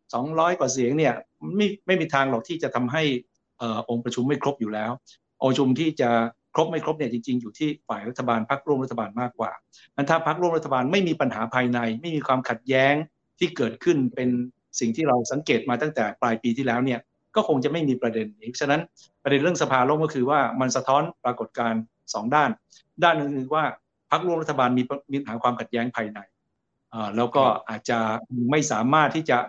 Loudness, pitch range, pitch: -24 LUFS, 120-150 Hz, 130 Hz